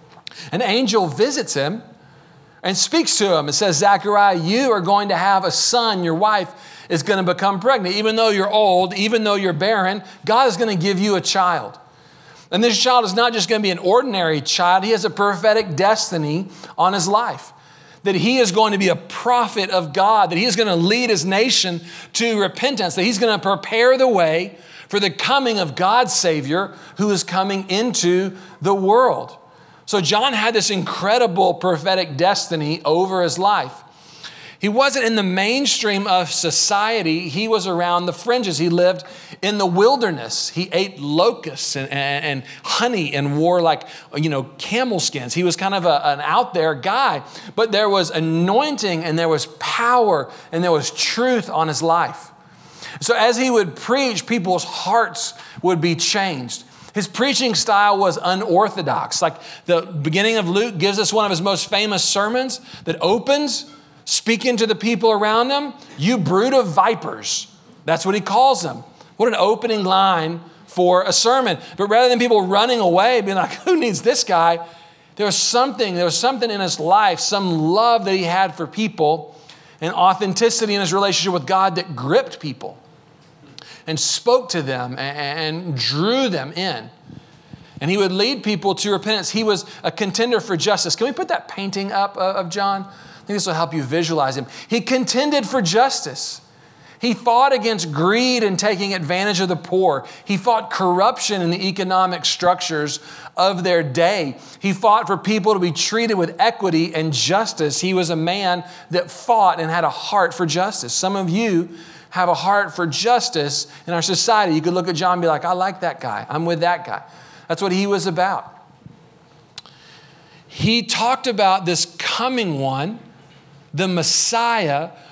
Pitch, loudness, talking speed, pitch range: 190 Hz, -18 LUFS, 180 wpm, 170-220 Hz